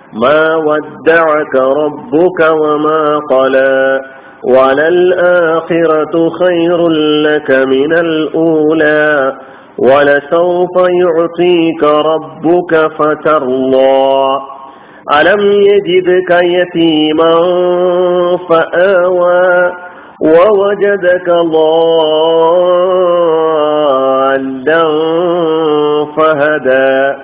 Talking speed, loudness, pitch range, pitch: 45 wpm, -9 LUFS, 150-175 Hz, 160 Hz